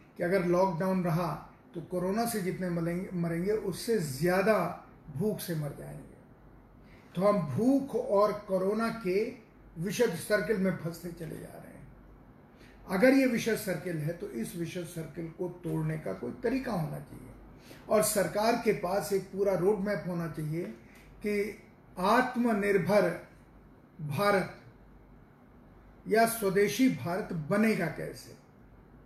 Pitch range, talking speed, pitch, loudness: 170-210 Hz, 130 wpm, 190 Hz, -30 LUFS